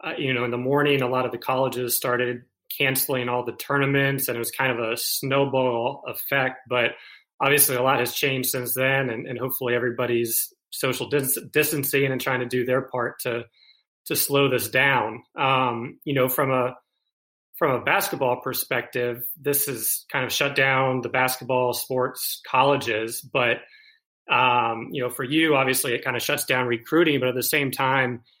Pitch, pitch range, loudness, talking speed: 130 Hz, 125-140 Hz, -23 LUFS, 185 wpm